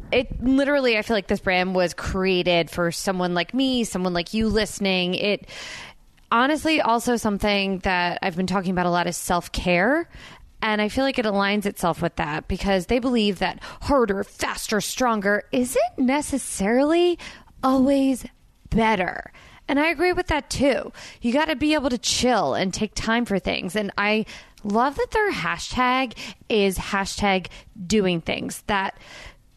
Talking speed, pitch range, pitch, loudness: 160 wpm, 190-260 Hz, 215 Hz, -22 LUFS